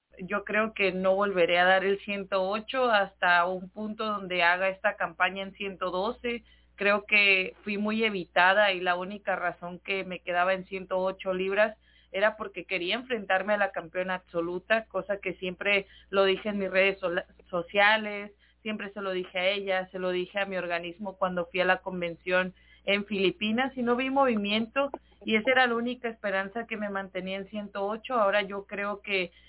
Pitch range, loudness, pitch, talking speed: 185-210 Hz, -28 LUFS, 195 Hz, 180 wpm